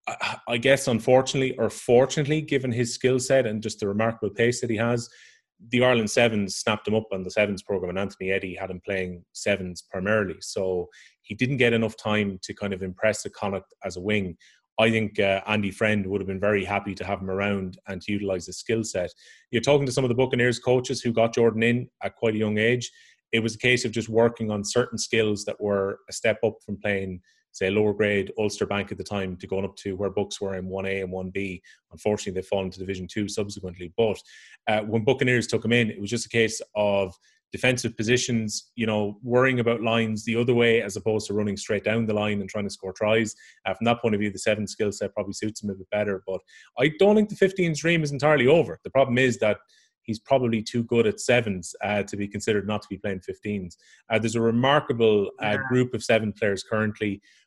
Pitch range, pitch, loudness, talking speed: 100-120 Hz, 105 Hz, -25 LUFS, 230 wpm